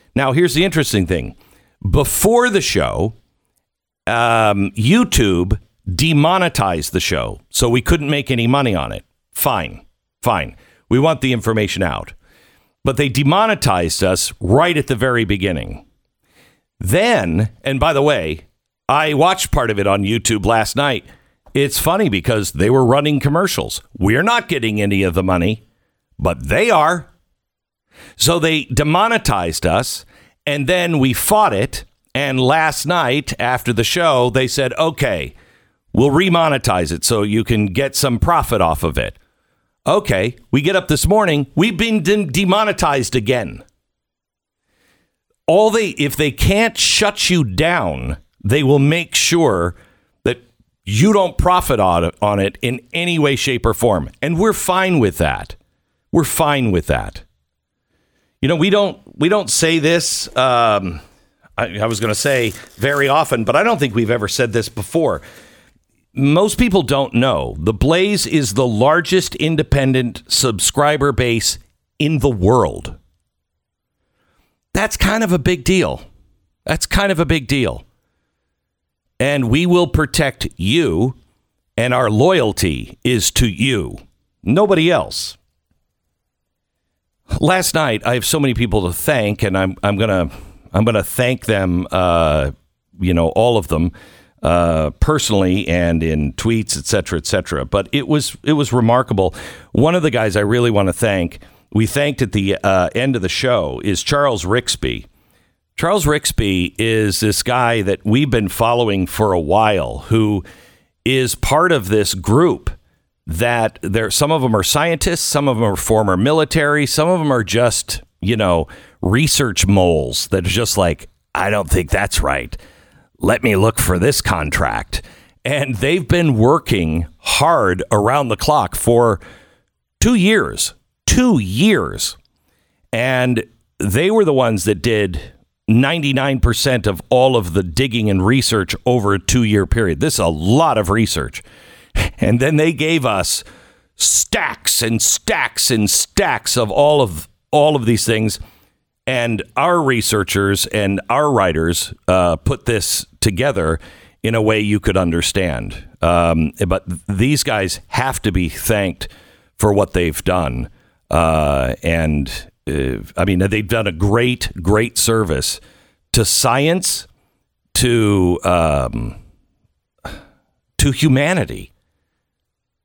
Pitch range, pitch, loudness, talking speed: 95-140 Hz, 115 Hz, -16 LUFS, 145 wpm